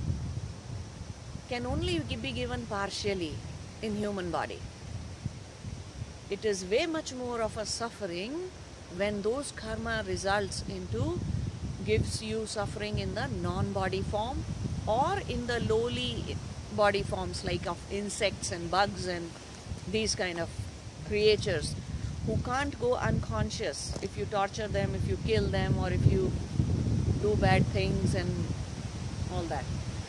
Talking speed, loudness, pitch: 130 wpm, -32 LUFS, 175 Hz